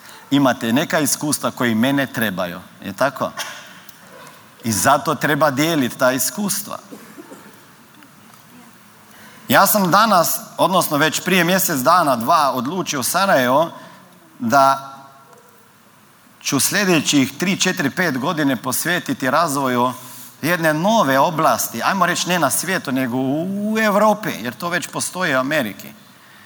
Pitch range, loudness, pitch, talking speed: 135-185 Hz, -17 LUFS, 155 Hz, 115 wpm